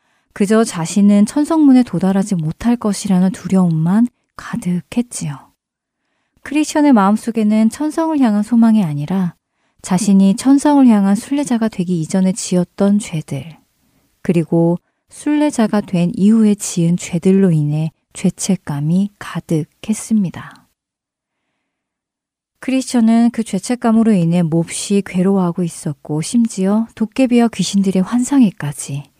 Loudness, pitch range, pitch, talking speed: -15 LUFS, 175-230 Hz, 195 Hz, 285 characters per minute